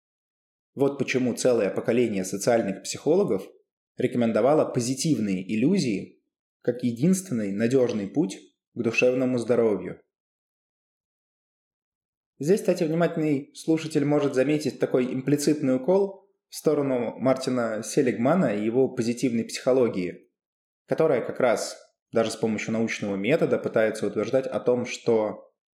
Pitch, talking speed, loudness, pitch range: 125 Hz, 105 wpm, -25 LUFS, 115-145 Hz